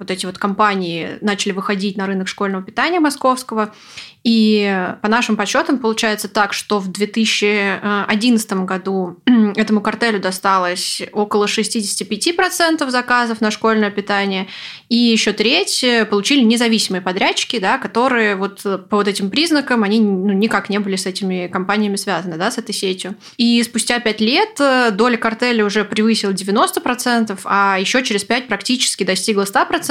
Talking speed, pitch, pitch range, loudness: 140 wpm, 210 Hz, 200-235 Hz, -16 LUFS